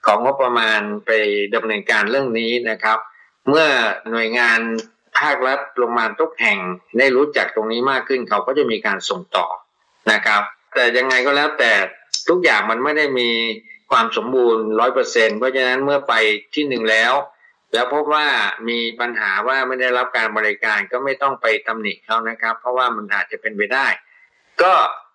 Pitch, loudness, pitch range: 115 Hz, -17 LUFS, 110-130 Hz